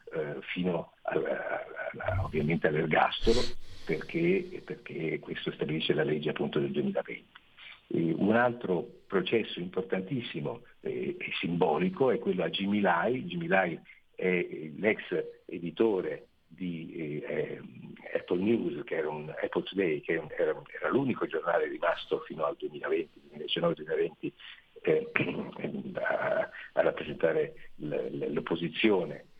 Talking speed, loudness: 115 wpm, -31 LUFS